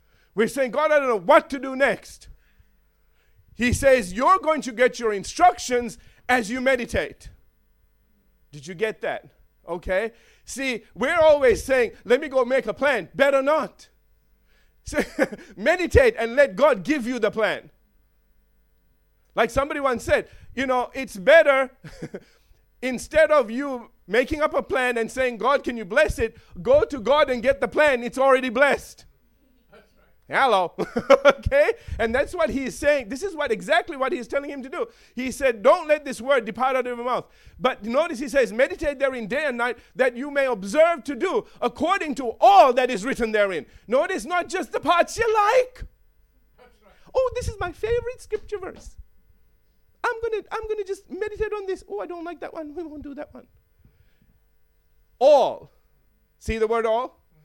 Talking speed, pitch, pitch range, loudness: 175 wpm, 275 Hz, 240-320 Hz, -22 LUFS